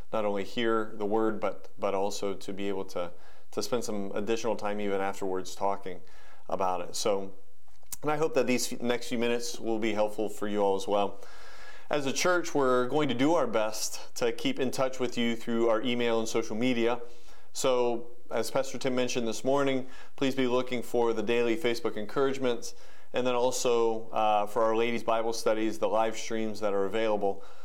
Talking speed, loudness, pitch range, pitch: 195 wpm, -30 LUFS, 105-125 Hz, 115 Hz